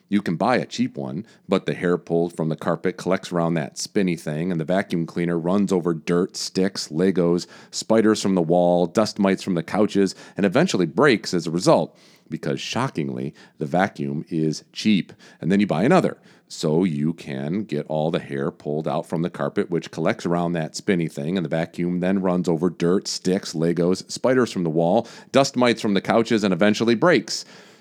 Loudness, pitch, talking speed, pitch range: -22 LUFS, 90 Hz, 200 wpm, 85-100 Hz